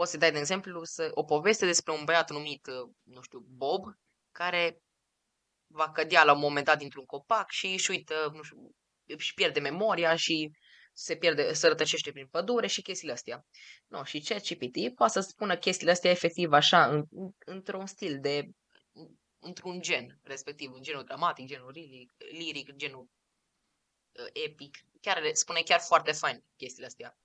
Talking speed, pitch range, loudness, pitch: 165 wpm, 145-190 Hz, -29 LUFS, 165 Hz